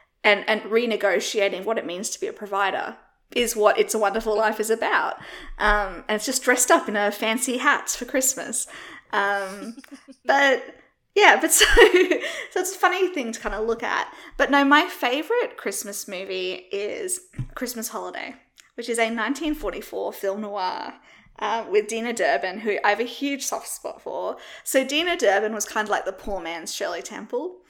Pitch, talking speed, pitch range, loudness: 235 Hz, 180 wpm, 210-305 Hz, -22 LUFS